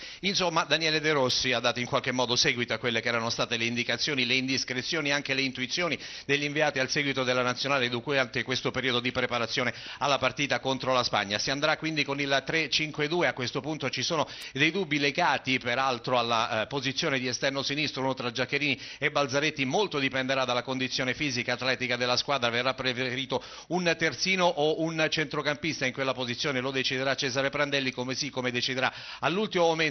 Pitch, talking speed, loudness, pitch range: 135 Hz, 185 wpm, -27 LUFS, 125-150 Hz